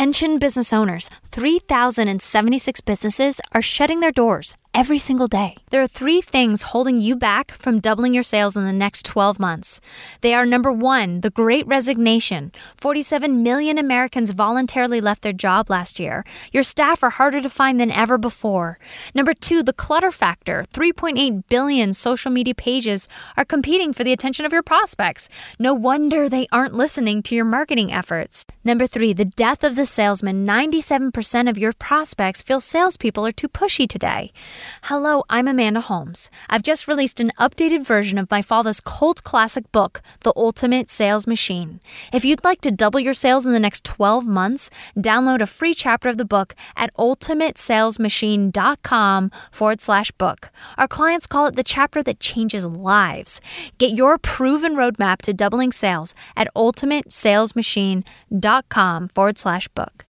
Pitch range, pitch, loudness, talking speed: 210-275 Hz, 245 Hz, -18 LUFS, 160 wpm